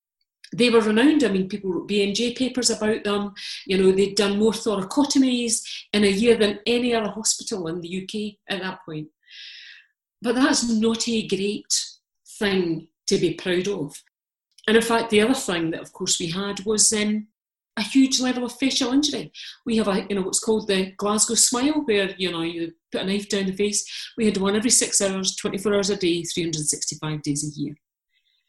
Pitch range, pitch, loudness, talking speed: 190-235 Hz, 210 Hz, -22 LUFS, 195 wpm